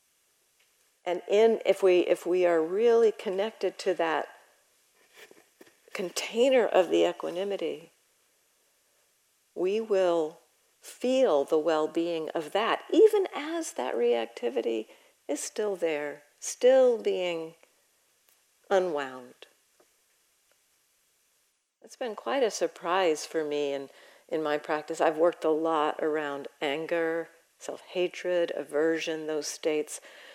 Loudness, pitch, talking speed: -28 LUFS, 170 Hz, 110 wpm